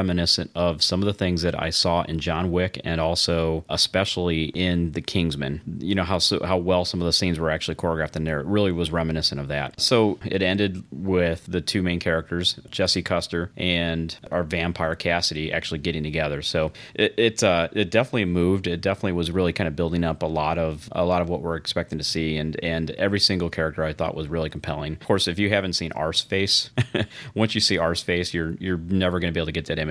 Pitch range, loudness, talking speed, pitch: 80-95 Hz, -23 LUFS, 230 wpm, 85 Hz